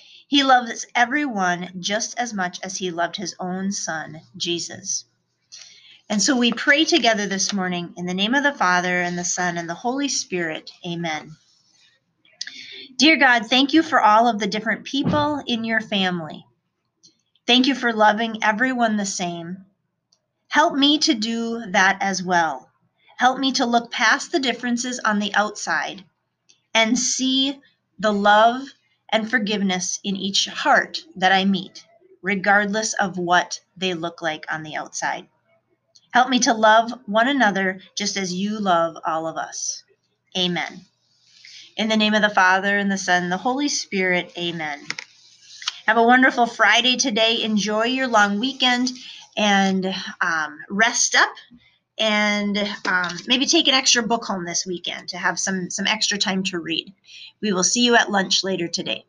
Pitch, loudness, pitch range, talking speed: 205 Hz, -20 LUFS, 180-240 Hz, 160 wpm